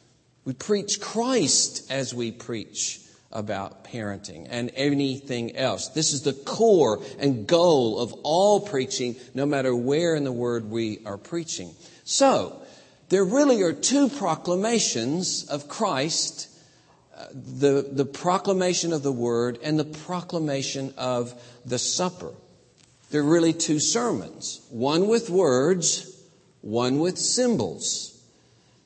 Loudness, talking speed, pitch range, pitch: -24 LUFS, 125 wpm, 125-180 Hz, 145 Hz